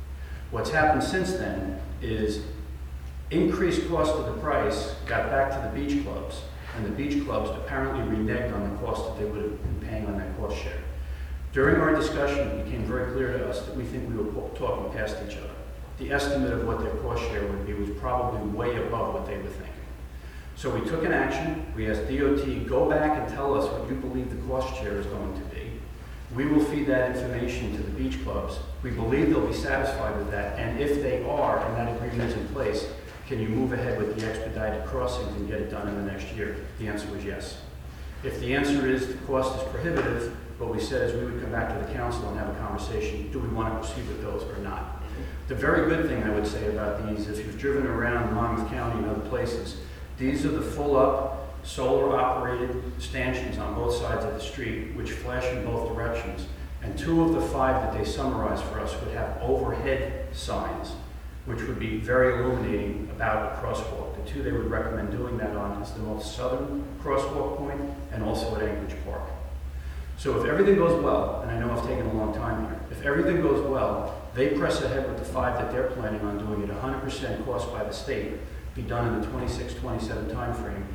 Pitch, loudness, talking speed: 105 Hz, -28 LUFS, 215 wpm